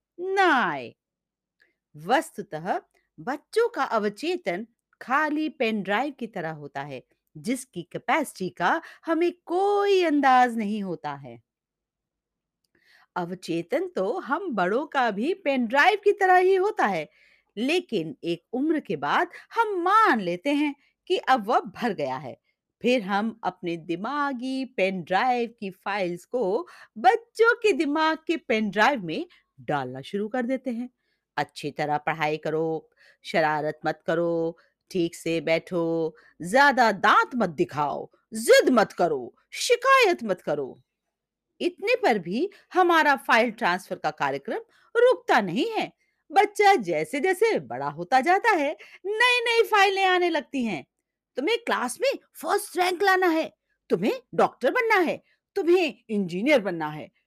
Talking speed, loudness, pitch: 135 wpm, -24 LUFS, 260 Hz